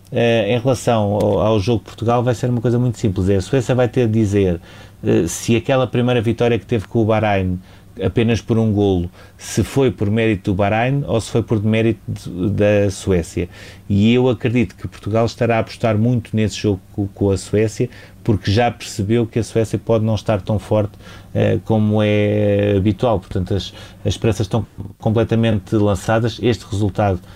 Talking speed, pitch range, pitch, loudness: 195 wpm, 100-115 Hz, 110 Hz, -18 LUFS